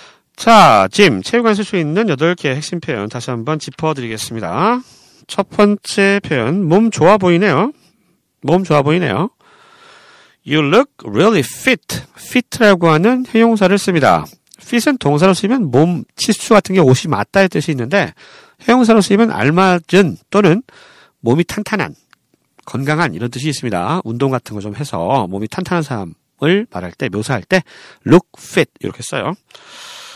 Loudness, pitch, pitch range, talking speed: -14 LUFS, 185 Hz, 150-220 Hz, 325 characters per minute